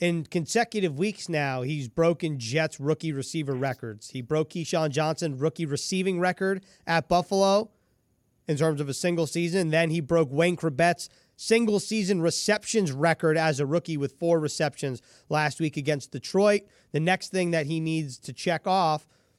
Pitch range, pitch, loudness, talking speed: 150-180 Hz, 160 Hz, -26 LUFS, 165 wpm